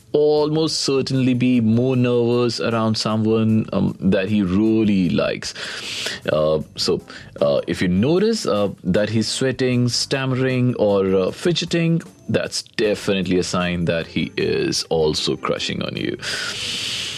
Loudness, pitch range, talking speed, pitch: -20 LUFS, 100-130 Hz, 130 wpm, 115 Hz